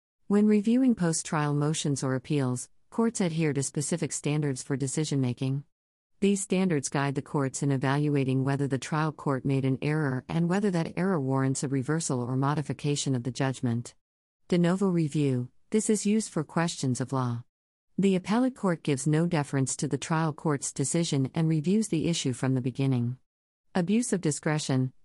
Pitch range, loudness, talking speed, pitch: 135-170 Hz, -28 LUFS, 170 wpm, 145 Hz